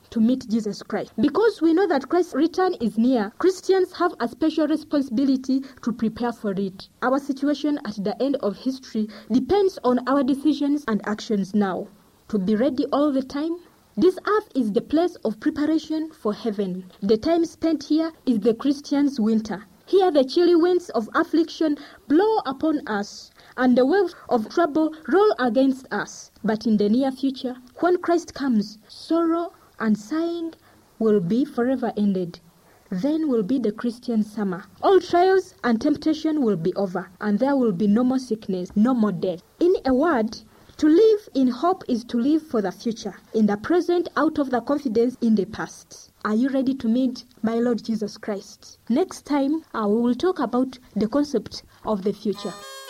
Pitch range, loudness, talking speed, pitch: 215-315 Hz, -23 LUFS, 180 wpm, 255 Hz